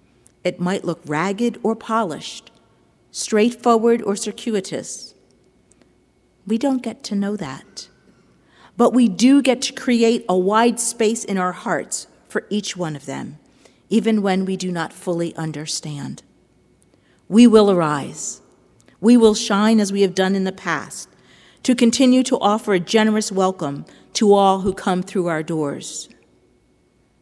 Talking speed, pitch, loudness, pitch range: 145 wpm, 205 Hz, -19 LUFS, 180-230 Hz